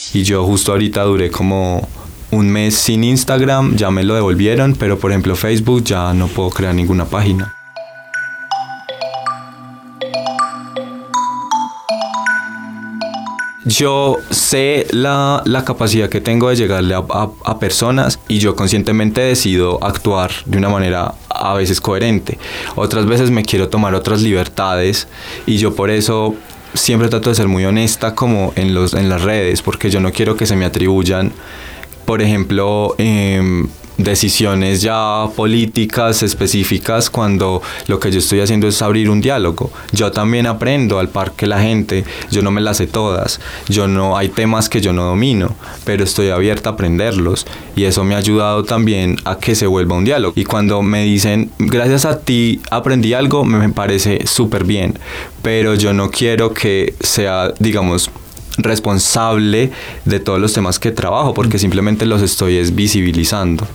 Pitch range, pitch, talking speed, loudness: 95-115 Hz, 105 Hz, 160 wpm, -14 LUFS